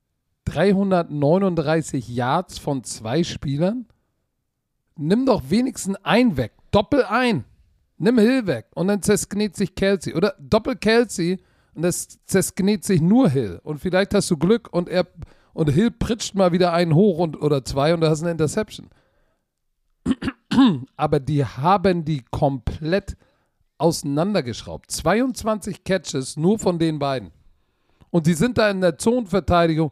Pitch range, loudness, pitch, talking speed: 150-205 Hz, -21 LUFS, 175 Hz, 140 wpm